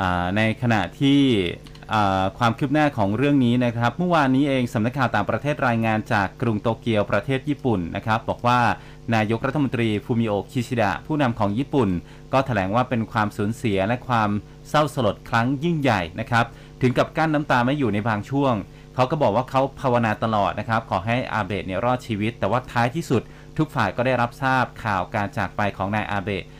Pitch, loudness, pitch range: 120 Hz, -22 LUFS, 105-135 Hz